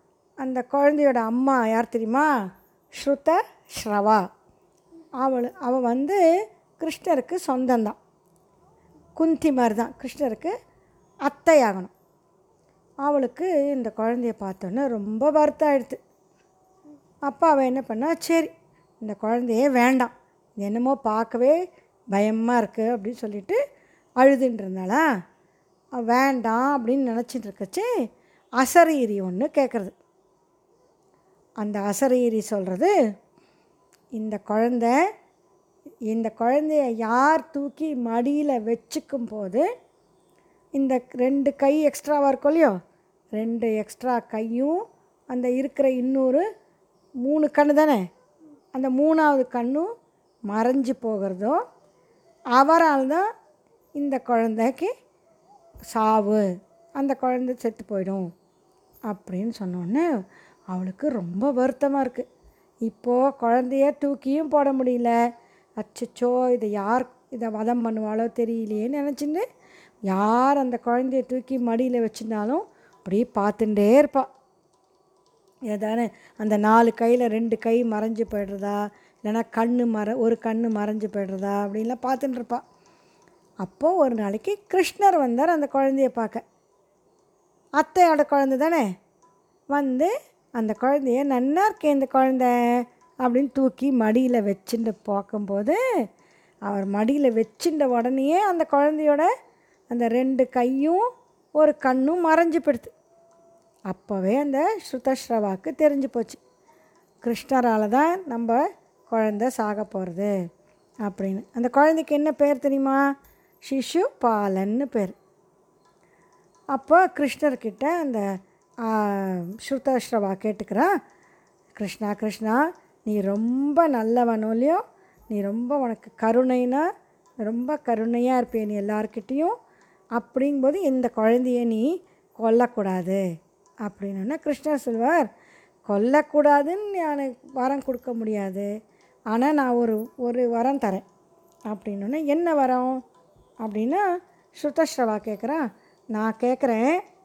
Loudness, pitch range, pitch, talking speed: -23 LUFS, 220-290 Hz, 250 Hz, 95 wpm